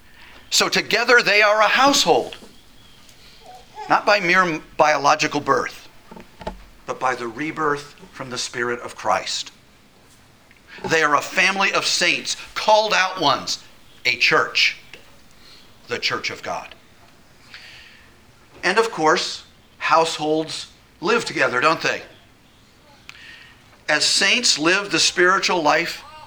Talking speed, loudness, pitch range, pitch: 110 wpm, -18 LUFS, 150-210 Hz, 170 Hz